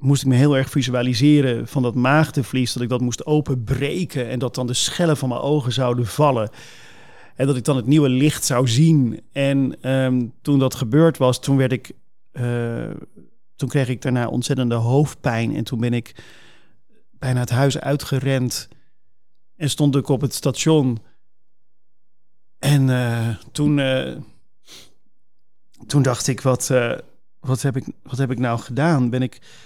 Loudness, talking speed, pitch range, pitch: -20 LUFS, 165 wpm, 125-140 Hz, 130 Hz